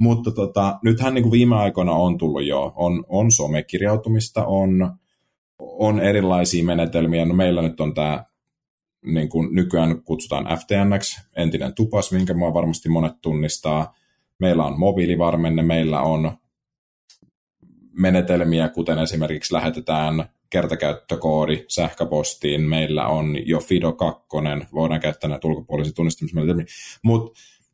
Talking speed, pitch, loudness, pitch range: 115 wpm, 85 Hz, -21 LUFS, 80-95 Hz